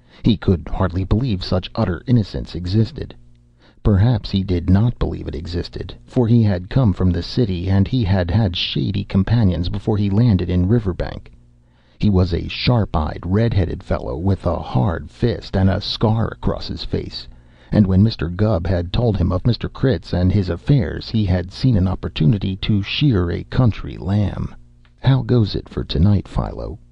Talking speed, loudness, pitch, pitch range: 175 wpm, -19 LUFS, 95 Hz, 85-110 Hz